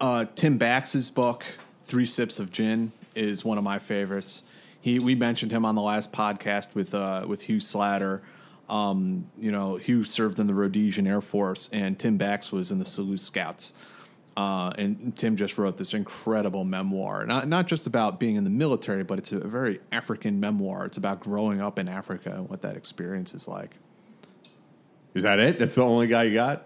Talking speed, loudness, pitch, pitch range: 195 wpm, -27 LUFS, 110 Hz, 100-125 Hz